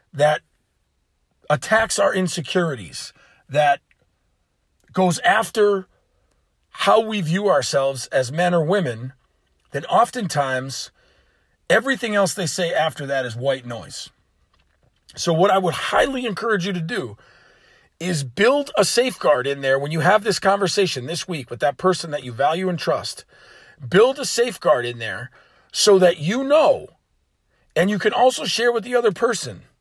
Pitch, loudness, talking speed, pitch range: 175 Hz, -20 LUFS, 150 wpm, 135-205 Hz